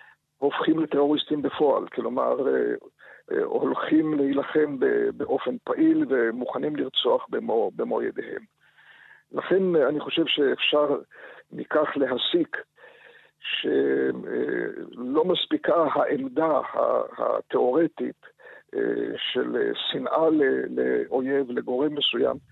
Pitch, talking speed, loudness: 365 Hz, 75 wpm, -25 LUFS